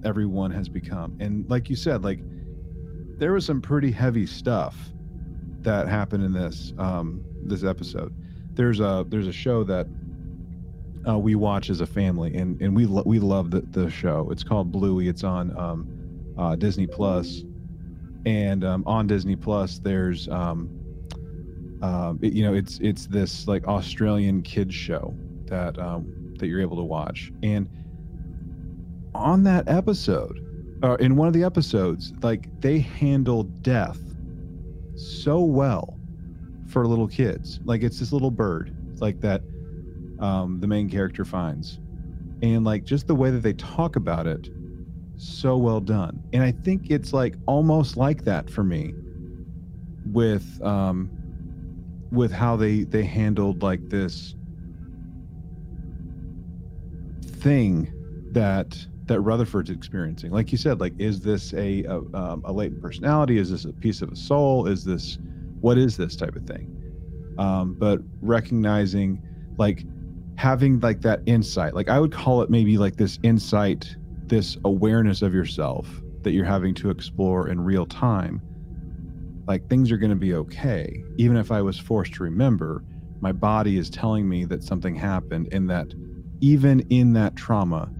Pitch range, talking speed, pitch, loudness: 85-110 Hz, 155 wpm, 95 Hz, -24 LUFS